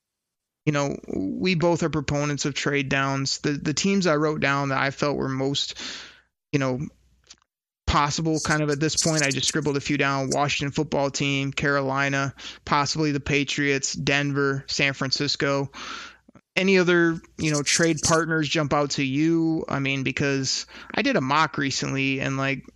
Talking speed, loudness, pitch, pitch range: 170 wpm, -23 LUFS, 145 Hz, 135-155 Hz